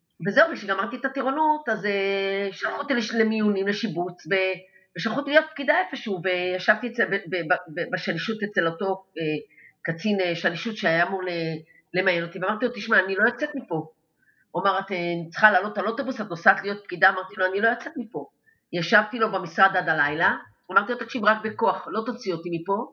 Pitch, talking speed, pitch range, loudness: 195 Hz, 185 wpm, 180-225 Hz, -24 LUFS